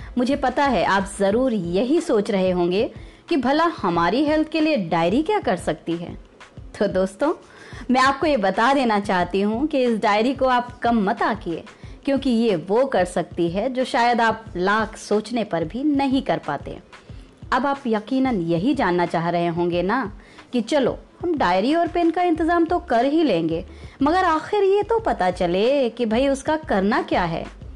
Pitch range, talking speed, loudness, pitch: 195-290 Hz, 190 wpm, -21 LUFS, 245 Hz